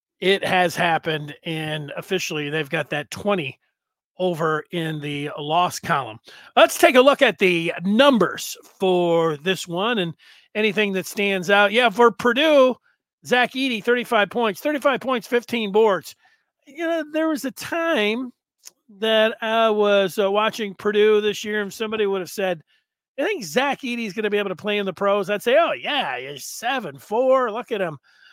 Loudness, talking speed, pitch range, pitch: -21 LUFS, 175 wpm, 180-245 Hz, 210 Hz